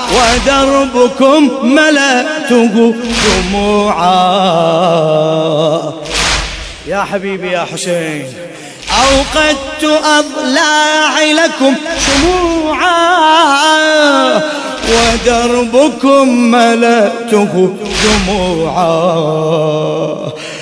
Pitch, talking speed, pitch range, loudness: 235 Hz, 40 wpm, 180-295 Hz, -10 LUFS